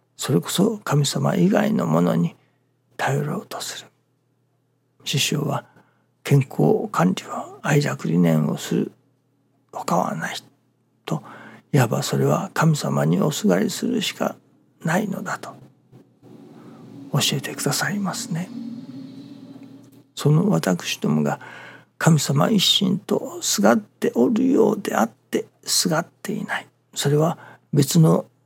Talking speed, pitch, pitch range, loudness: 225 characters per minute, 150 Hz, 135-200 Hz, -21 LUFS